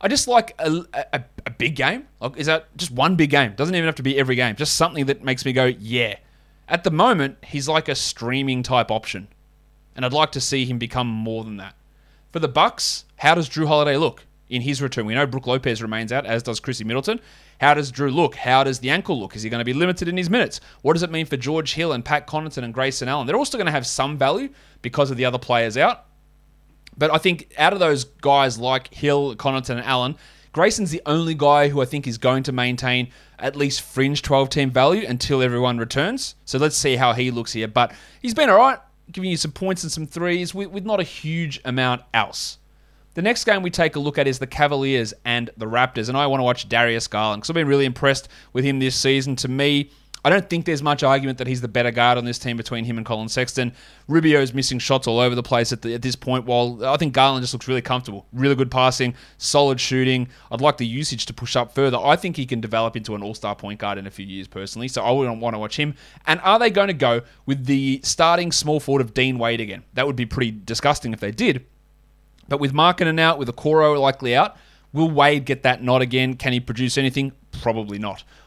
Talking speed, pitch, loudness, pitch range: 245 wpm, 135 Hz, -20 LUFS, 125-150 Hz